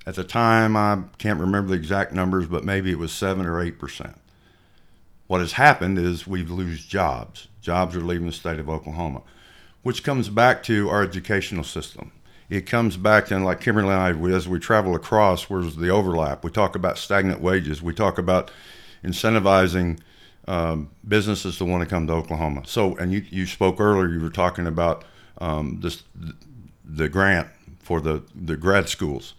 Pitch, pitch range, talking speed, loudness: 90 Hz, 85-100 Hz, 180 wpm, -22 LUFS